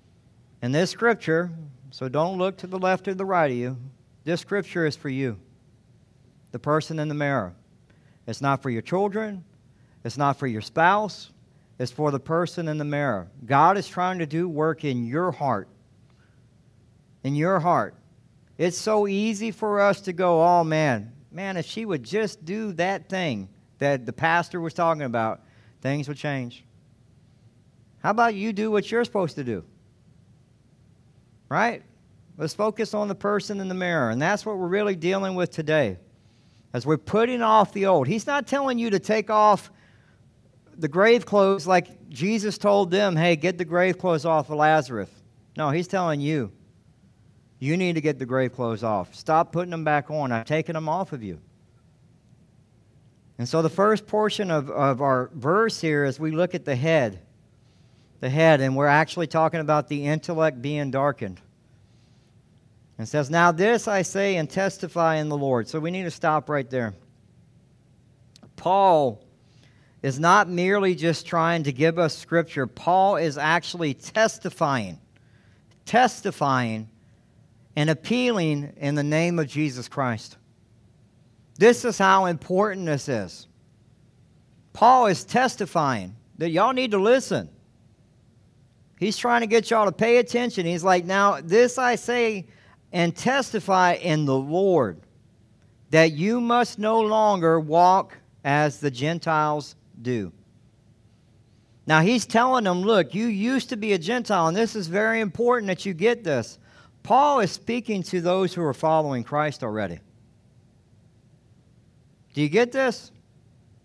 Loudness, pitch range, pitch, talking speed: -23 LUFS, 130-190 Hz, 160 Hz, 160 wpm